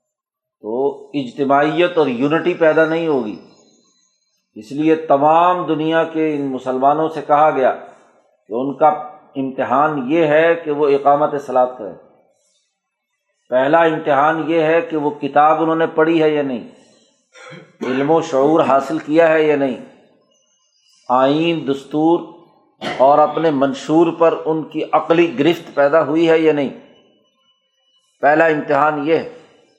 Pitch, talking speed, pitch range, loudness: 155 Hz, 135 wpm, 145-165 Hz, -16 LUFS